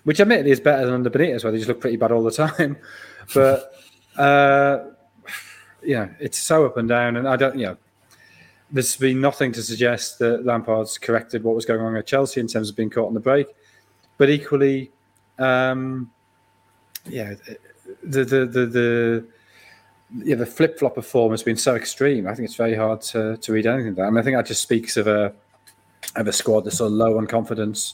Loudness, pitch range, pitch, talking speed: -20 LUFS, 110-135 Hz, 120 Hz, 215 wpm